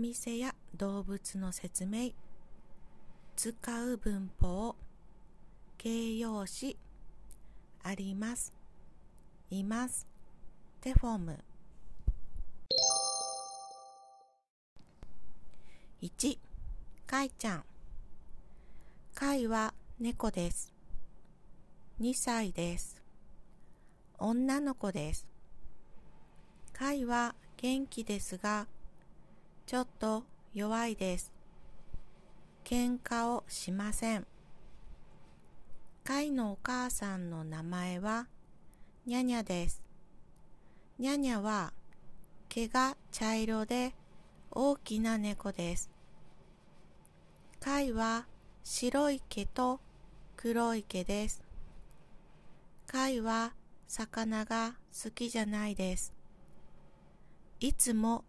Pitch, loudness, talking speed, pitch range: 215 Hz, -36 LUFS, 130 characters per minute, 180-240 Hz